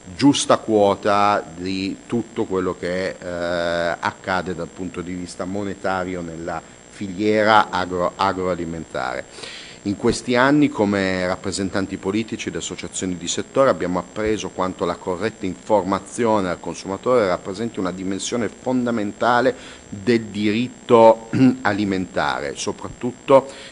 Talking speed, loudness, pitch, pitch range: 110 wpm, -21 LUFS, 95 Hz, 90-110 Hz